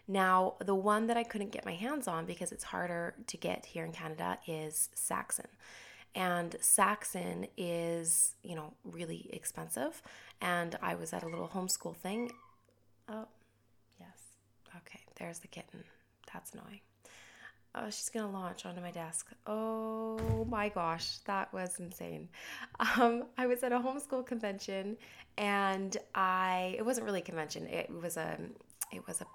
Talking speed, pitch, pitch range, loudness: 155 wpm, 185 Hz, 170-220 Hz, -36 LUFS